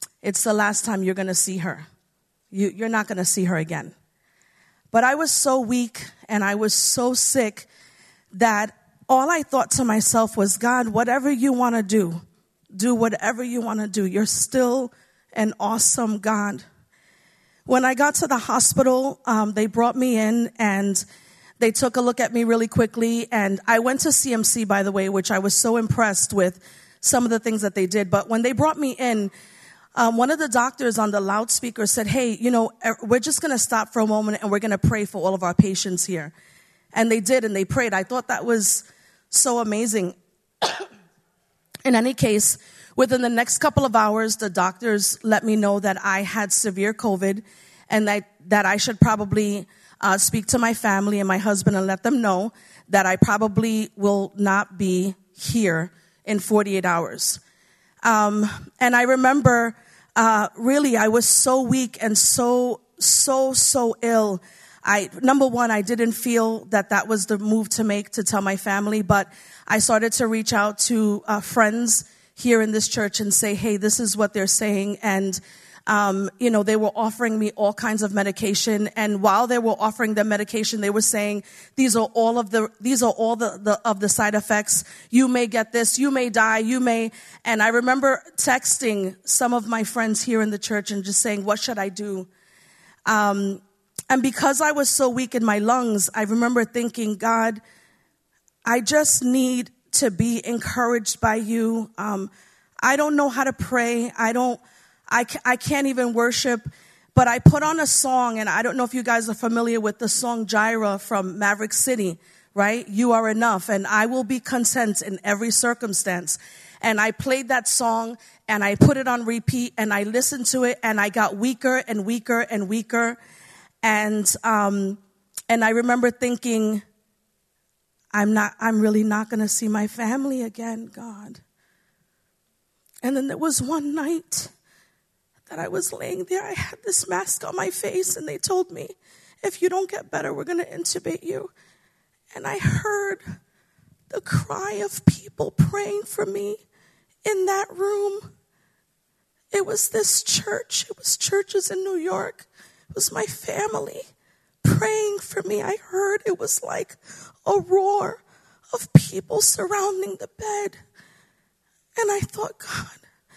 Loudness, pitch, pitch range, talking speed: -21 LUFS, 225 Hz, 205-250 Hz, 180 wpm